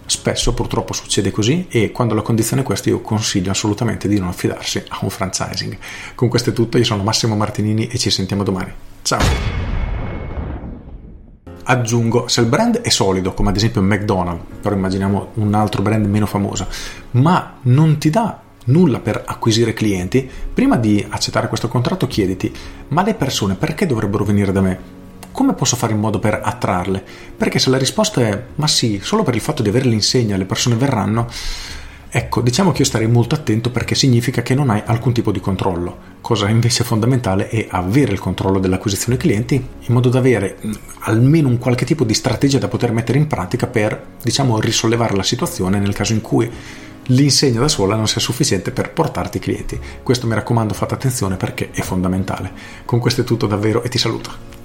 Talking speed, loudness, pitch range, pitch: 190 wpm, -17 LUFS, 100-125 Hz, 110 Hz